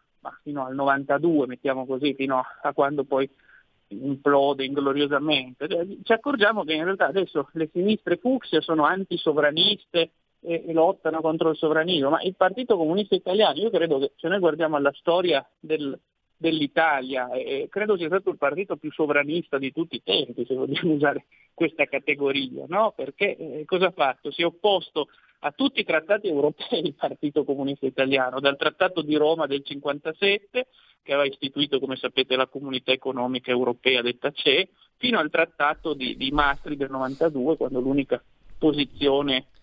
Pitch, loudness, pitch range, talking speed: 150 Hz, -24 LUFS, 140-170 Hz, 160 wpm